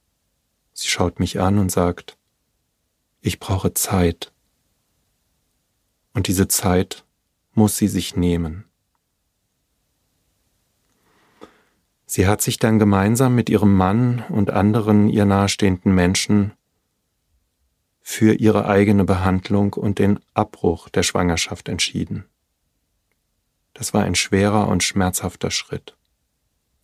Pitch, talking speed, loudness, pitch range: 100 Hz, 105 wpm, -19 LUFS, 90-105 Hz